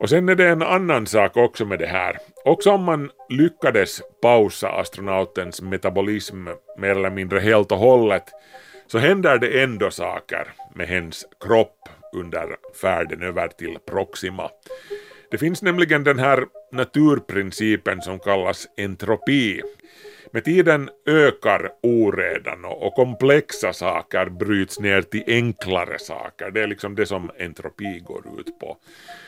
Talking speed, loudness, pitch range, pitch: 135 wpm, -20 LUFS, 100-165 Hz, 125 Hz